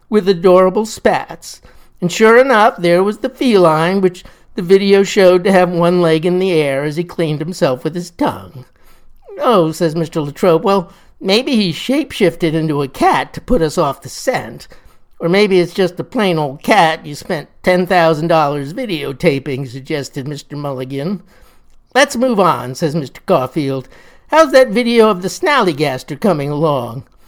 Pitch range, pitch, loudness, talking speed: 155-195 Hz, 175 Hz, -14 LUFS, 170 wpm